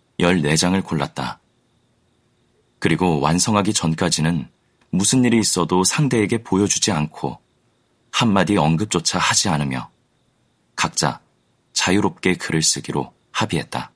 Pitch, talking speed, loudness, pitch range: 90 Hz, 260 characters per minute, -19 LUFS, 80-105 Hz